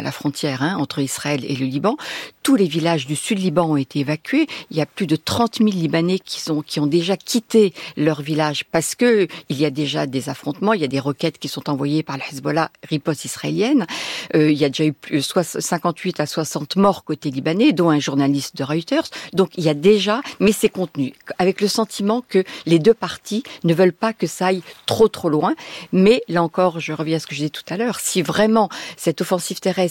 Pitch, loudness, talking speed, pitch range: 165 Hz, -20 LUFS, 235 wpm, 150-195 Hz